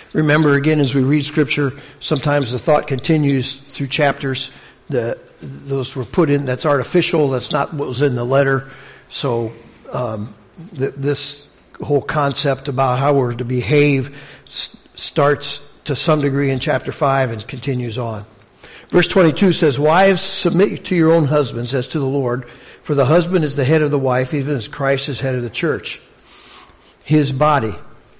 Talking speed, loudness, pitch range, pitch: 165 wpm, -17 LUFS, 130-150 Hz, 140 Hz